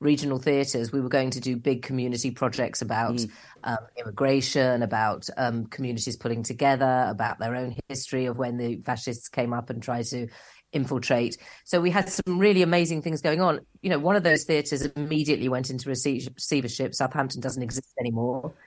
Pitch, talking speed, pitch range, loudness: 130 Hz, 175 wpm, 120-140 Hz, -26 LUFS